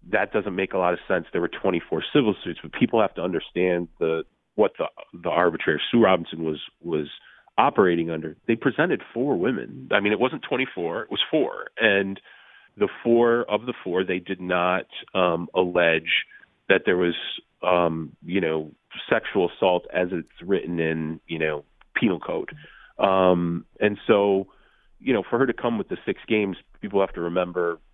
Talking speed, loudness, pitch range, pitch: 185 wpm, -24 LUFS, 85-100 Hz, 90 Hz